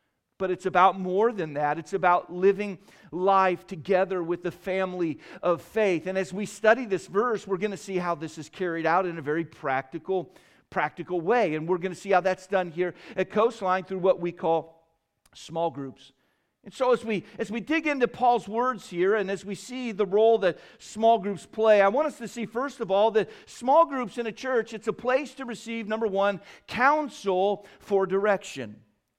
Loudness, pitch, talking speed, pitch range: -26 LUFS, 195 Hz, 205 wpm, 175-220 Hz